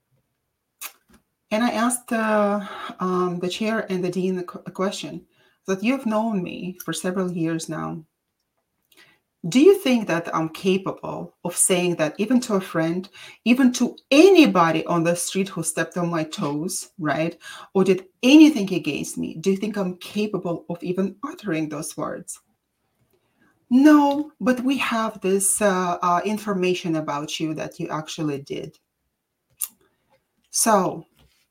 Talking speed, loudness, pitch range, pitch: 145 wpm, -22 LUFS, 165-215 Hz, 185 Hz